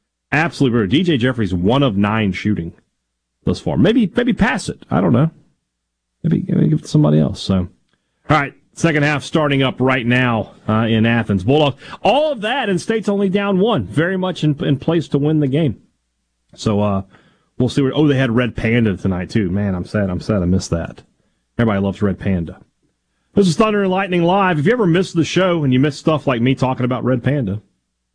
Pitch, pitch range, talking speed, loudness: 130 Hz, 100-160 Hz, 215 wpm, -17 LUFS